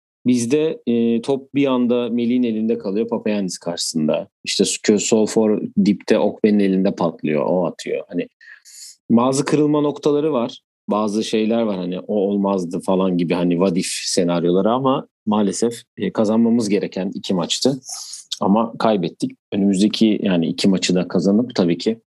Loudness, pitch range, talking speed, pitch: -19 LUFS, 100-120 Hz, 140 wpm, 110 Hz